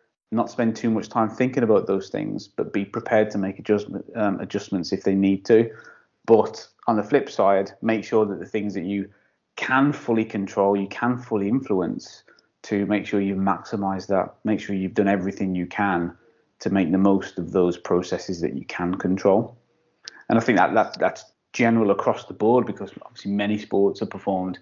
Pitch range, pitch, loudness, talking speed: 95-110 Hz, 100 Hz, -23 LUFS, 195 wpm